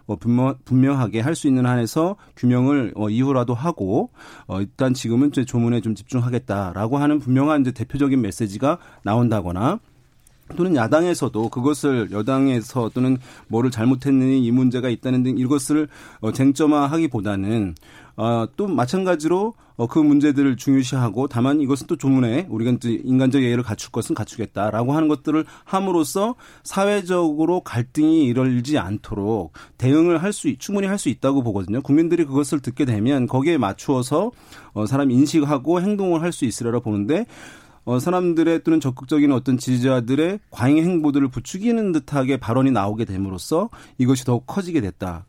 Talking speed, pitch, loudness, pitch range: 360 characters per minute, 130 Hz, -20 LUFS, 120-150 Hz